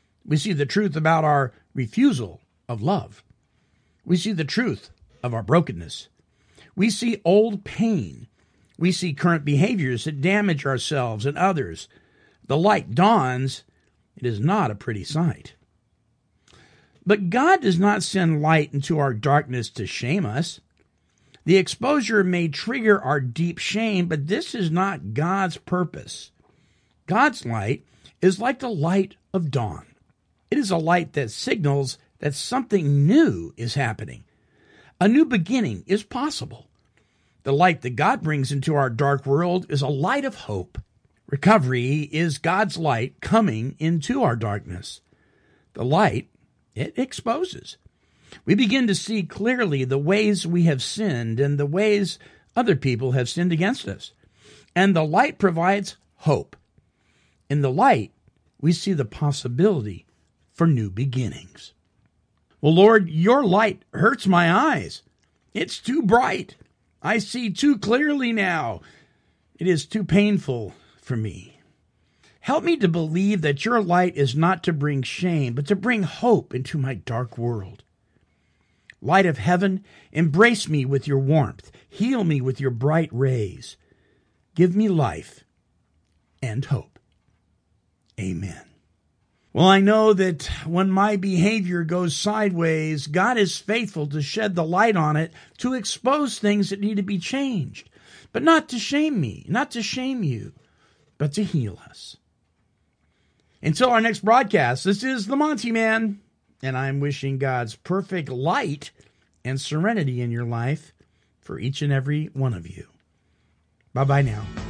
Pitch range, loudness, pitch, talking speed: 130-200 Hz, -22 LUFS, 160 Hz, 145 wpm